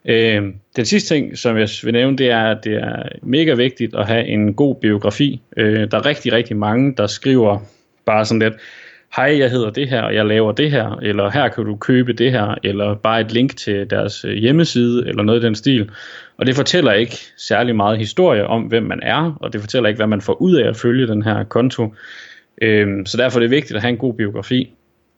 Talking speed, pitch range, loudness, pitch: 220 wpm, 105-125 Hz, -16 LUFS, 115 Hz